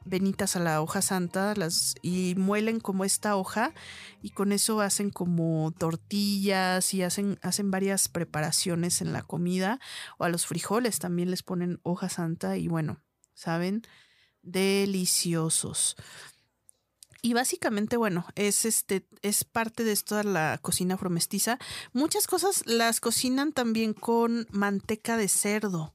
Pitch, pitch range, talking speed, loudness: 195 Hz, 180-215 Hz, 135 wpm, -28 LUFS